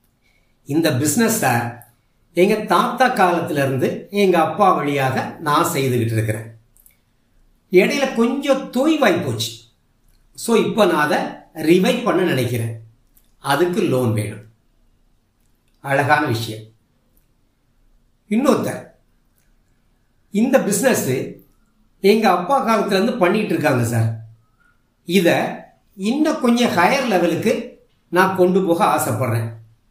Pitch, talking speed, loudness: 155 Hz, 85 wpm, -18 LUFS